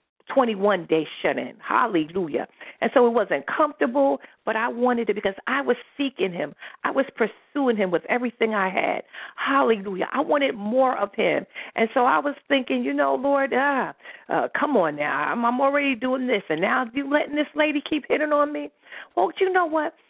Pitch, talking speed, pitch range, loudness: 255 Hz, 195 wpm, 220-285 Hz, -23 LUFS